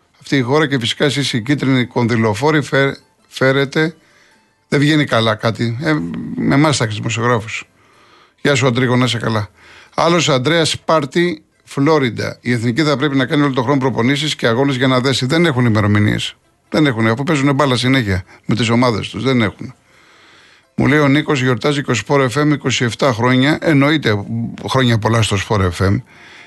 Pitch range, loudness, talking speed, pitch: 115-150 Hz, -15 LUFS, 165 wpm, 130 Hz